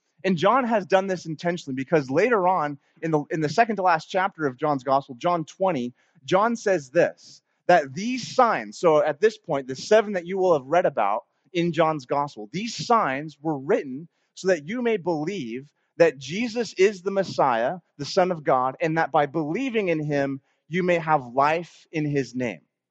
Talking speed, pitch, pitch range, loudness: 195 wpm, 165 Hz, 145-190 Hz, -24 LUFS